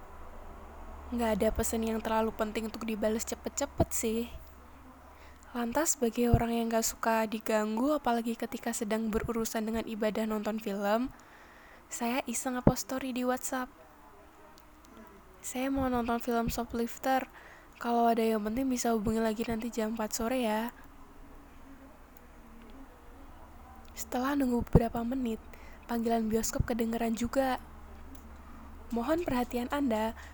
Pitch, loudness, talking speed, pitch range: 230 Hz, -32 LUFS, 115 wpm, 220-240 Hz